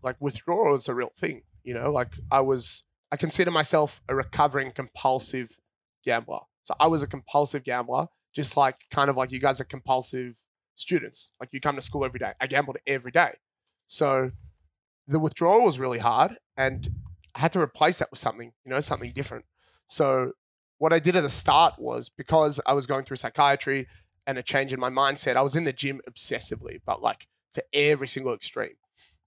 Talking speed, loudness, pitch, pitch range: 195 wpm, -25 LUFS, 135 Hz, 125-145 Hz